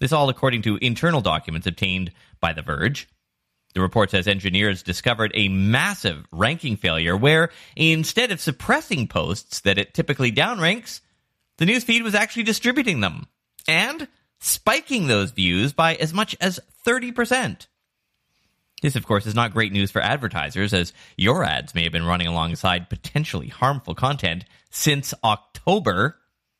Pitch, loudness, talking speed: 120 Hz, -21 LUFS, 145 wpm